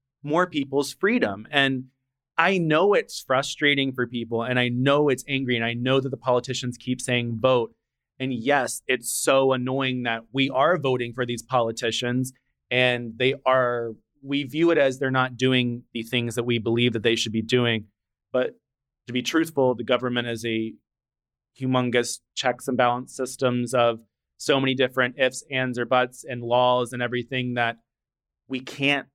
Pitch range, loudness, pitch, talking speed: 120-130 Hz, -24 LUFS, 125 Hz, 175 wpm